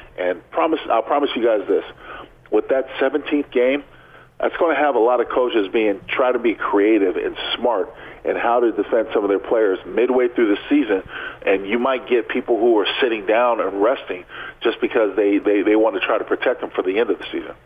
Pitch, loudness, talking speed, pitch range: 390 Hz, -19 LUFS, 225 wpm, 345-435 Hz